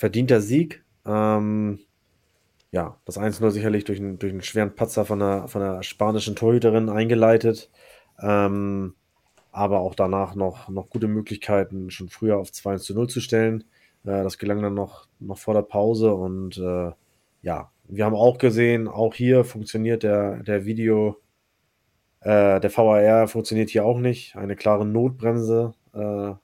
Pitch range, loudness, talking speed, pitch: 100-110 Hz, -22 LUFS, 150 wpm, 105 Hz